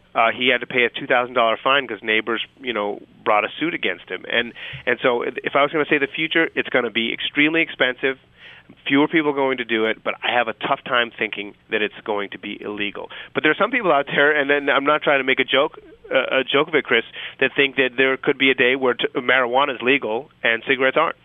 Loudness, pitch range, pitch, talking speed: -19 LUFS, 120-150 Hz, 135 Hz, 260 wpm